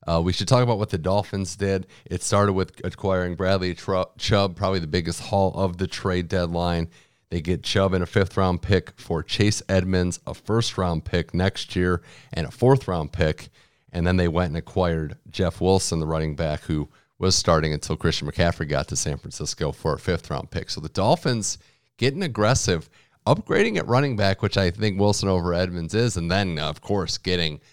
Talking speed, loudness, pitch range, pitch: 200 wpm, -24 LUFS, 85-100 Hz, 95 Hz